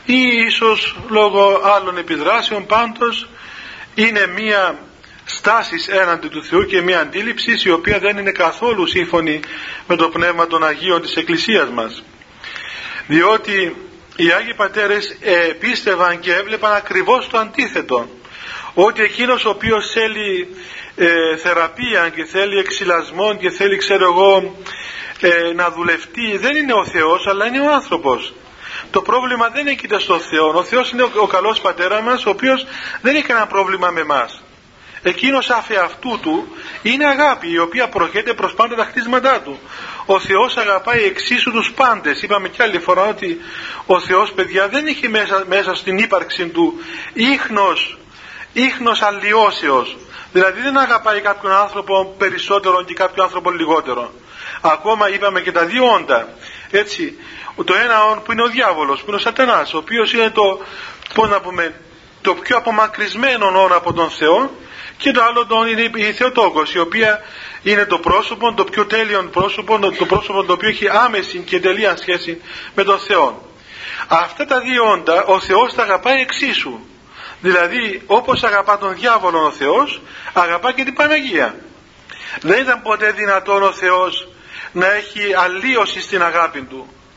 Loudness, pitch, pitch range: -15 LUFS, 205 Hz, 185-235 Hz